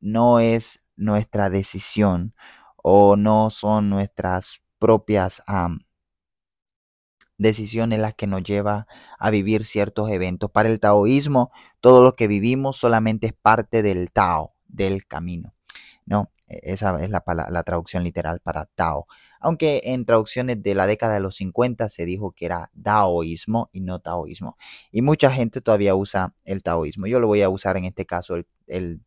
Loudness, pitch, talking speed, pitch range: -21 LUFS, 105 Hz, 160 wpm, 95-110 Hz